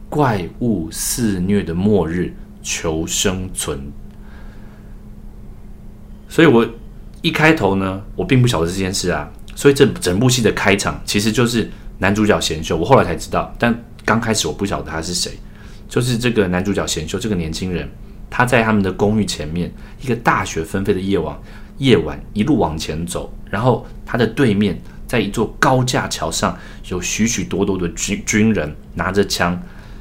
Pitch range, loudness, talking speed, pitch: 85-110 Hz, -18 LUFS, 250 characters per minute, 100 Hz